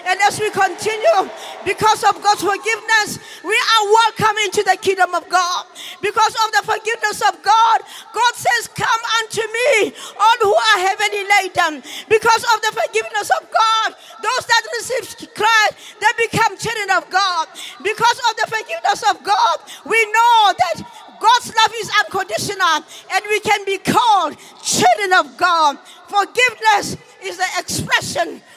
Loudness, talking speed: -16 LUFS, 150 wpm